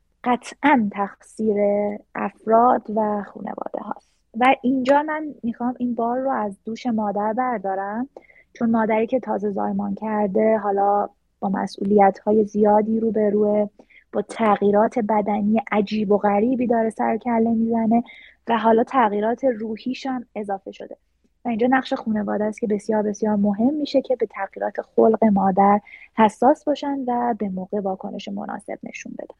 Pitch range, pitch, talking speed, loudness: 210-245 Hz, 220 Hz, 145 wpm, -21 LUFS